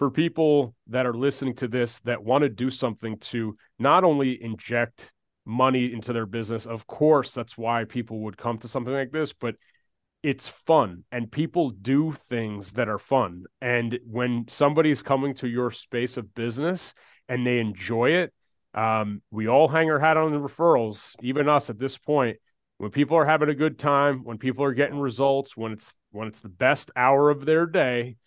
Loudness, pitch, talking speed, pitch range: -25 LUFS, 125 Hz, 190 wpm, 115-145 Hz